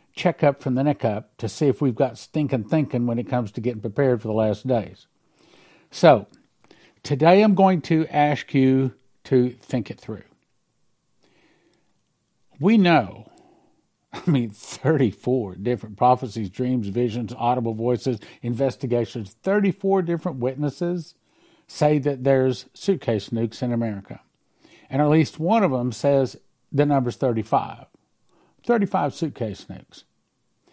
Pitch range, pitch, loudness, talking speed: 120-155 Hz, 130 Hz, -22 LUFS, 135 wpm